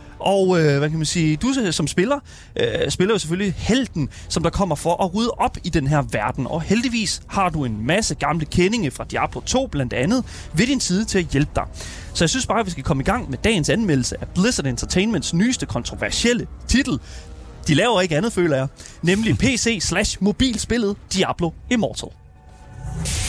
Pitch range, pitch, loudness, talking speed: 145-220 Hz, 180 Hz, -20 LUFS, 190 wpm